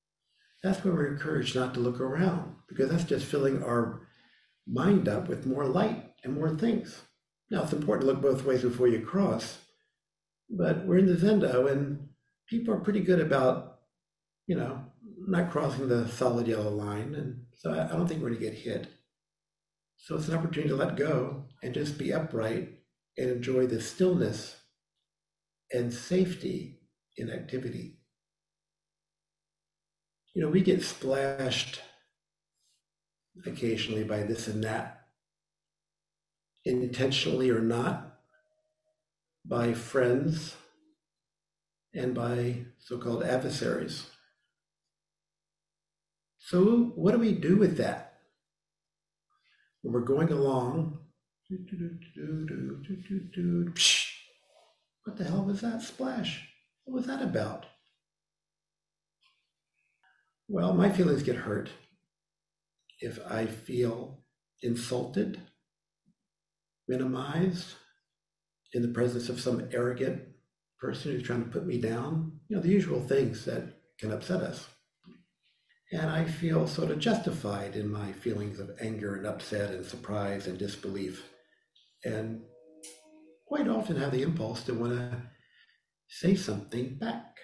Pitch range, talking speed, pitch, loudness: 125-180 Hz, 130 wpm, 155 Hz, -30 LUFS